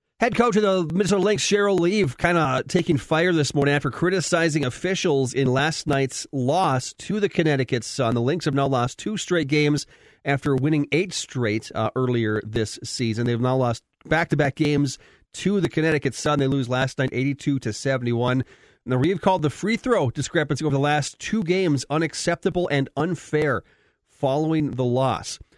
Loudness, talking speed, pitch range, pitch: -23 LUFS, 180 wpm, 130-175 Hz, 145 Hz